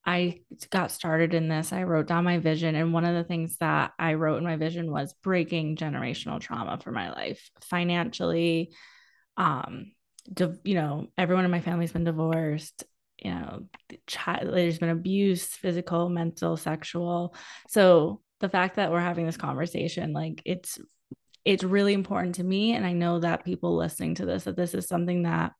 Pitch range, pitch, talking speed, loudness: 160-180 Hz, 170 Hz, 185 wpm, -27 LUFS